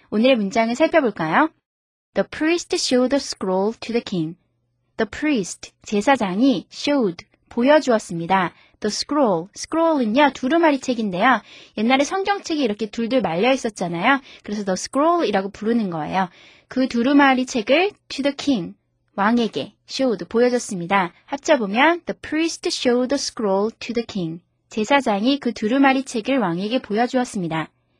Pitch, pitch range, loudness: 240 Hz, 205-280 Hz, -20 LUFS